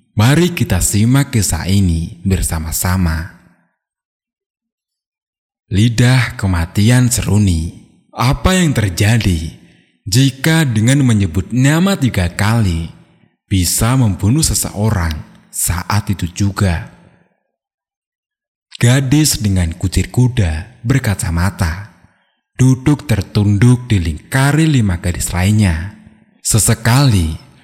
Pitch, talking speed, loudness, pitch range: 105 Hz, 80 wpm, -14 LUFS, 95-125 Hz